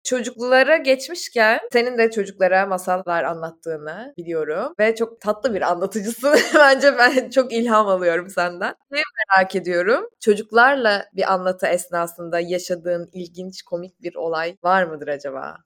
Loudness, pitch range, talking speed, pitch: -19 LUFS, 175-240 Hz, 130 wpm, 190 Hz